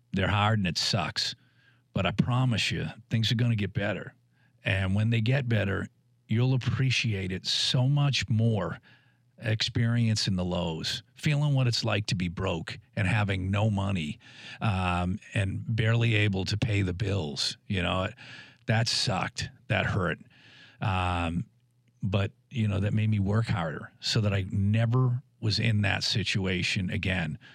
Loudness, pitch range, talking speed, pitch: -28 LUFS, 100-125 Hz, 155 wpm, 110 Hz